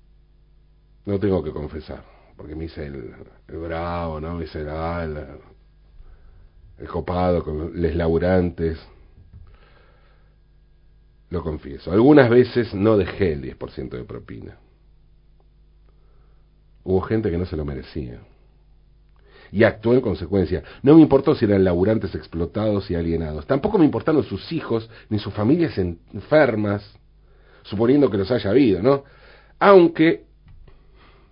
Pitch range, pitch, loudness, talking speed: 80-110 Hz, 90 Hz, -20 LUFS, 125 wpm